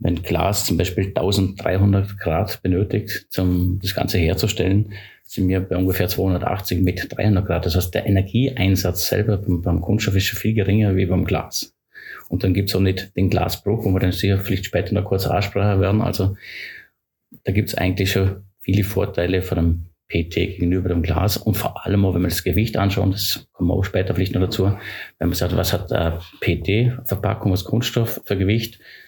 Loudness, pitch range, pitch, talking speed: -20 LUFS, 90-105 Hz, 95 Hz, 195 wpm